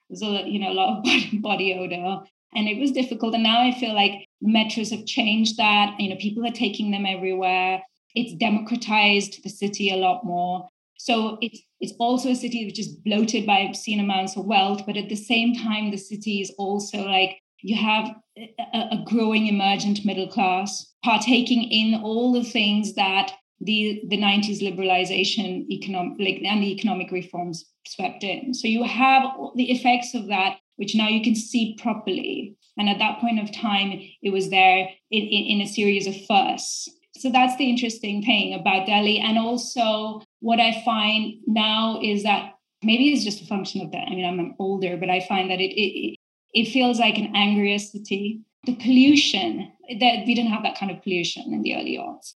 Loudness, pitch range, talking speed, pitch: -22 LUFS, 195-235 Hz, 190 wpm, 215 Hz